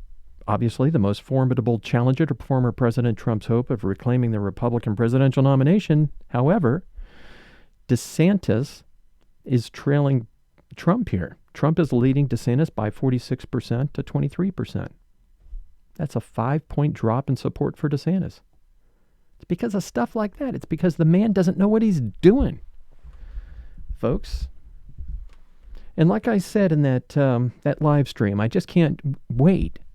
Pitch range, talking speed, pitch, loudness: 100-150 Hz, 140 wpm, 130 Hz, -22 LUFS